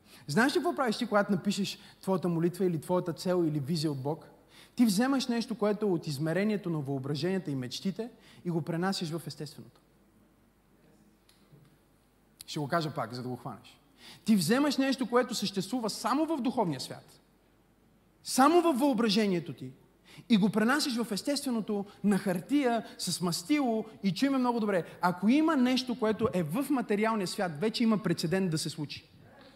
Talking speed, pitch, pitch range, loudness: 160 wpm, 195 Hz, 170-235 Hz, -30 LUFS